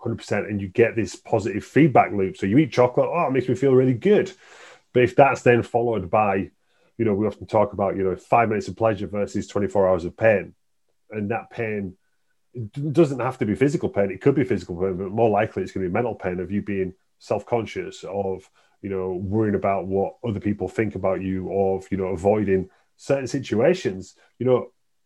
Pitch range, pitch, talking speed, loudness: 95-120 Hz, 105 Hz, 215 wpm, -22 LUFS